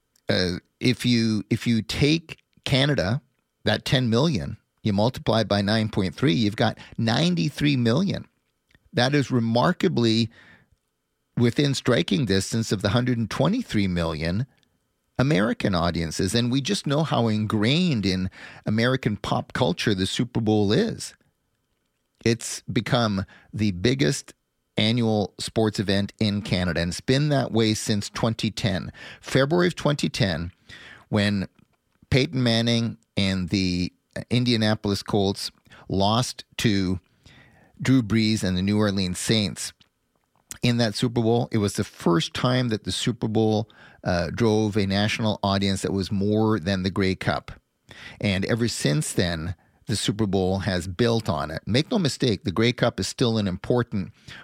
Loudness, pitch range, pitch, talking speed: -24 LUFS, 100-125 Hz, 110 Hz, 140 wpm